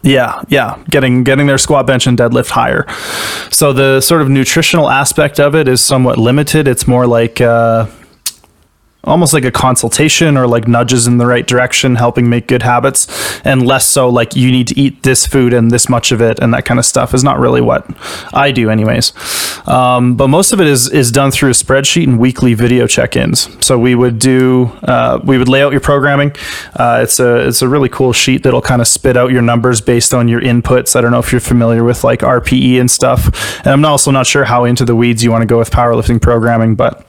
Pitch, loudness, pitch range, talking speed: 125 Hz, -9 LUFS, 120-135 Hz, 225 wpm